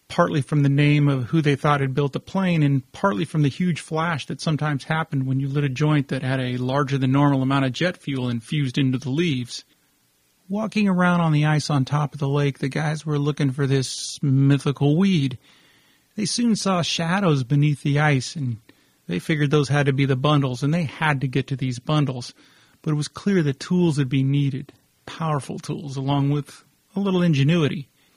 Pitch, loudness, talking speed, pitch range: 145 Hz, -22 LUFS, 210 wpm, 135-160 Hz